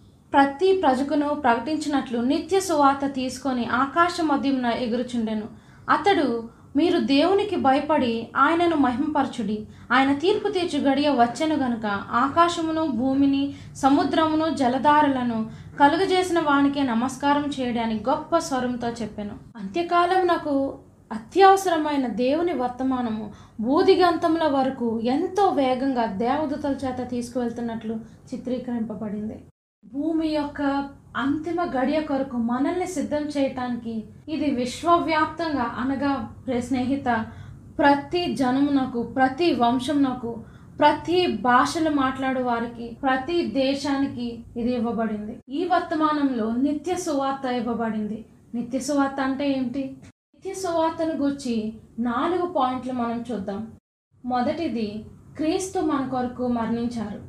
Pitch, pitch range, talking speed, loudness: 270 Hz, 240-310 Hz, 95 wpm, -23 LUFS